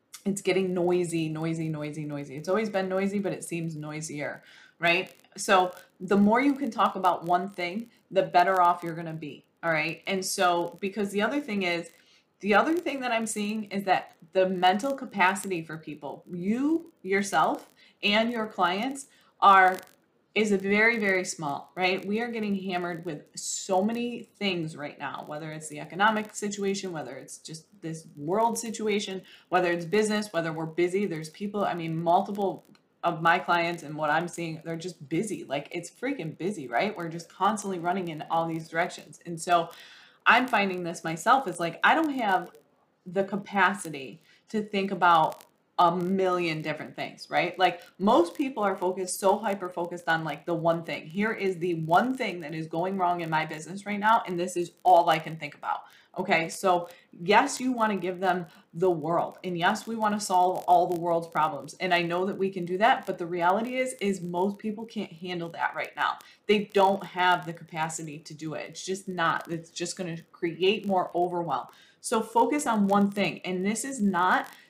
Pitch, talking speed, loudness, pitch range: 180 Hz, 195 wpm, -27 LUFS, 170-200 Hz